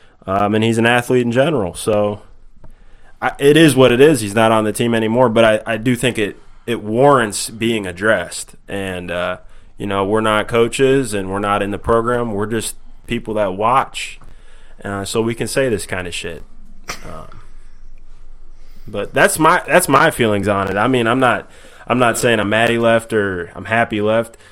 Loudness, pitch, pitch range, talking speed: -16 LUFS, 110 Hz, 100-120 Hz, 195 wpm